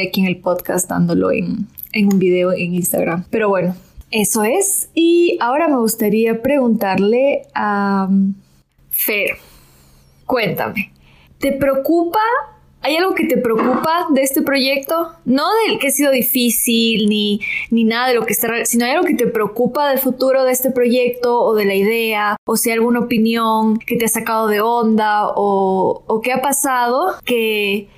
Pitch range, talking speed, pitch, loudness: 205-260 Hz, 165 wpm, 230 Hz, -16 LUFS